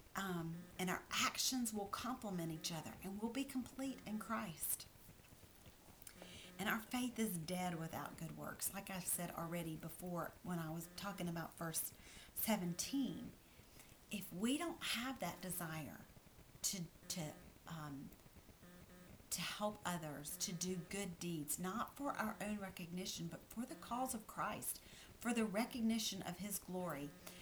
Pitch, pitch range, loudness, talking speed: 185 Hz, 165-220 Hz, -44 LUFS, 145 wpm